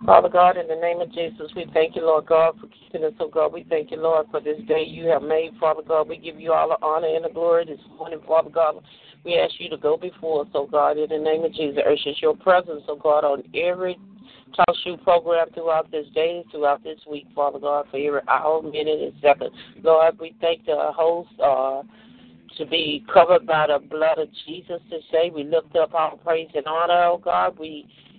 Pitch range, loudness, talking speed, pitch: 155-175 Hz, -21 LUFS, 225 wpm, 160 Hz